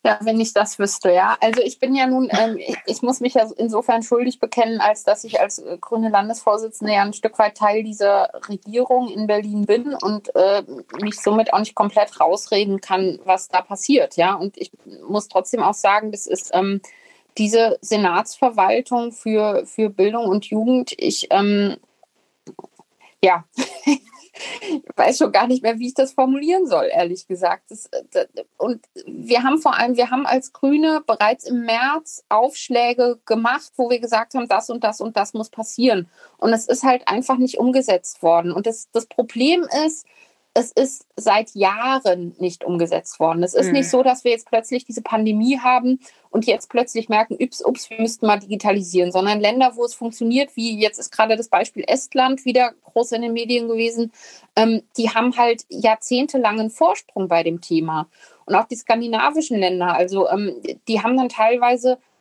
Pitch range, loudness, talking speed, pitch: 205-255 Hz, -19 LUFS, 175 wpm, 225 Hz